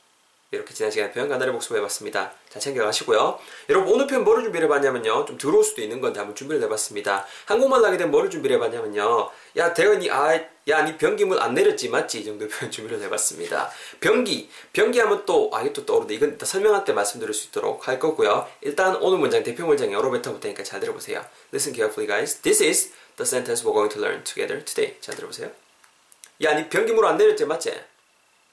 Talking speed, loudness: 530 characters per minute, -22 LUFS